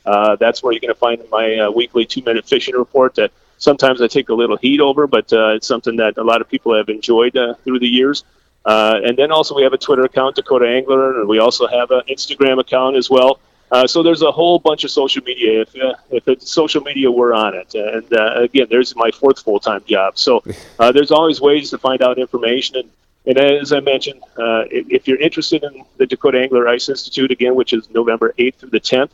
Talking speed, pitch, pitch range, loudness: 235 wpm, 130 Hz, 120-145 Hz, -14 LUFS